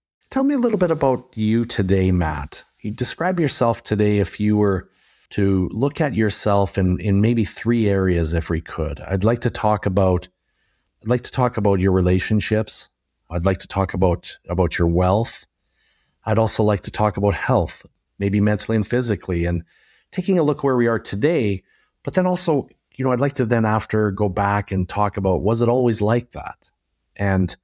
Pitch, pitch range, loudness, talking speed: 105 Hz, 95-120 Hz, -20 LUFS, 190 wpm